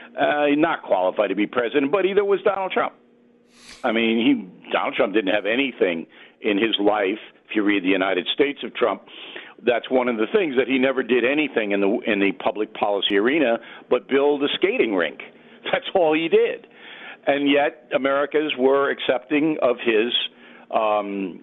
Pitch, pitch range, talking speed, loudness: 135 Hz, 110-155 Hz, 180 wpm, -21 LUFS